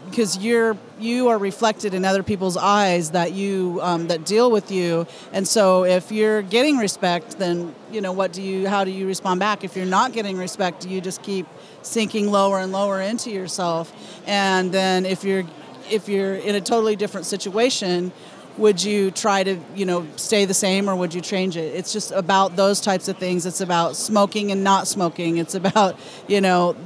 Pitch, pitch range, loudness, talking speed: 195 Hz, 185-205 Hz, -21 LUFS, 200 wpm